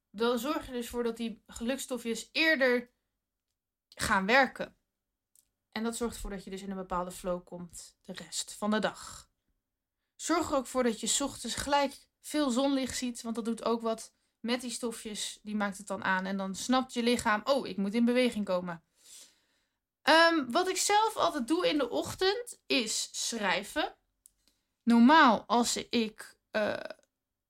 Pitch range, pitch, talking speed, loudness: 205-270 Hz, 235 Hz, 170 wpm, -30 LUFS